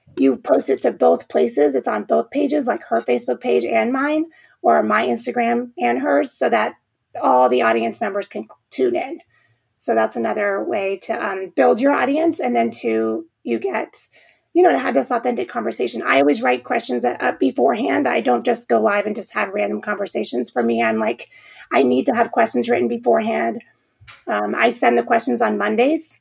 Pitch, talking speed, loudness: 200 Hz, 195 wpm, -19 LUFS